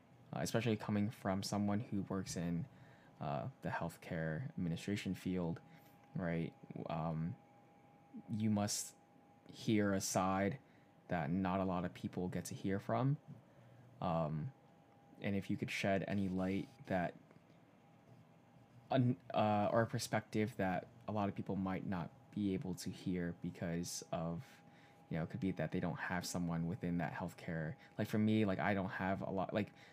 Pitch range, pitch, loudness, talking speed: 90-110 Hz, 100 Hz, -40 LUFS, 155 wpm